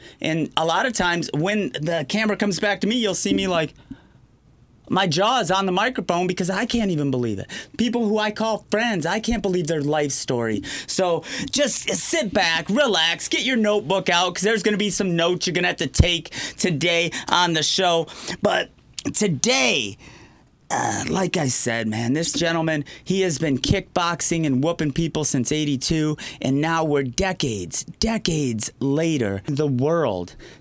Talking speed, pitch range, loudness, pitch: 180 wpm, 150-205 Hz, -21 LUFS, 170 Hz